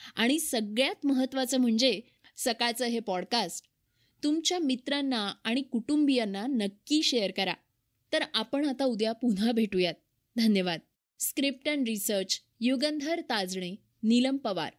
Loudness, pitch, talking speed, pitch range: -29 LUFS, 245 Hz, 115 wpm, 220-275 Hz